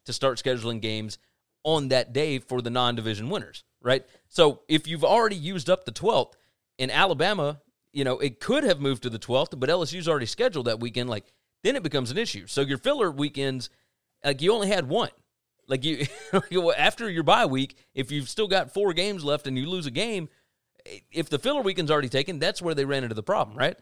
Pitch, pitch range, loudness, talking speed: 140 Hz, 130-175 Hz, -26 LUFS, 215 wpm